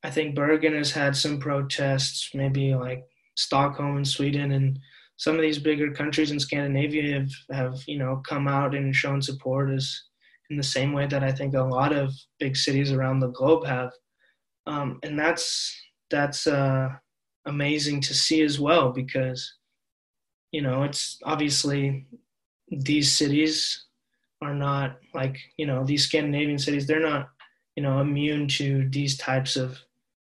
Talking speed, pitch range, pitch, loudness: 160 wpm, 135-150 Hz, 140 Hz, -25 LUFS